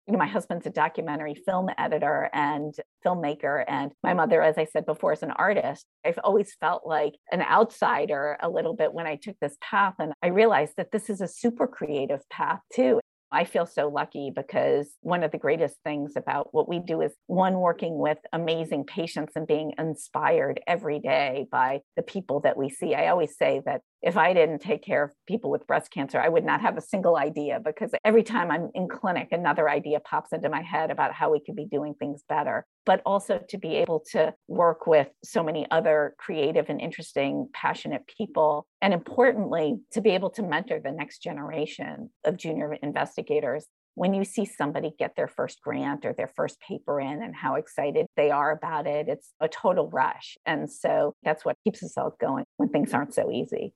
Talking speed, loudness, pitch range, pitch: 205 wpm, -27 LUFS, 150-215 Hz, 170 Hz